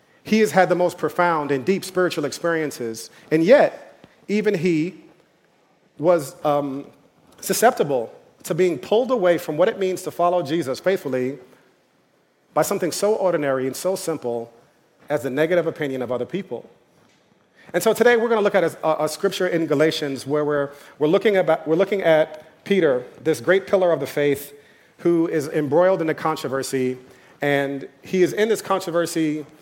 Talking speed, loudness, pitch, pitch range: 170 wpm, -21 LUFS, 165 Hz, 145-190 Hz